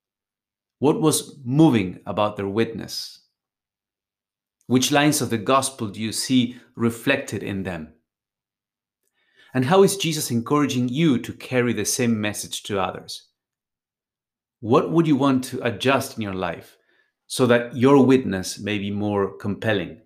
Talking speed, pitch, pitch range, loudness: 140 wpm, 115 Hz, 100-135 Hz, -22 LUFS